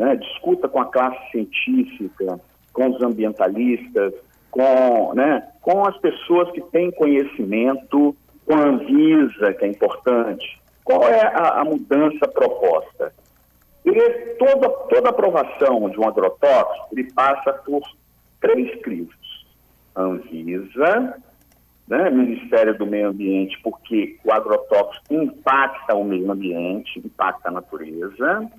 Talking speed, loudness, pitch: 120 wpm, -19 LUFS, 140 Hz